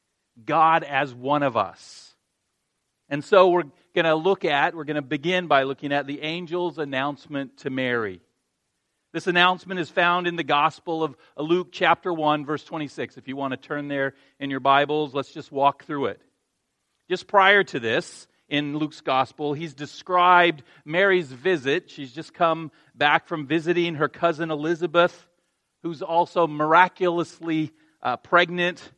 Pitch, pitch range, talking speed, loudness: 160 Hz, 145-175 Hz, 155 wpm, -23 LUFS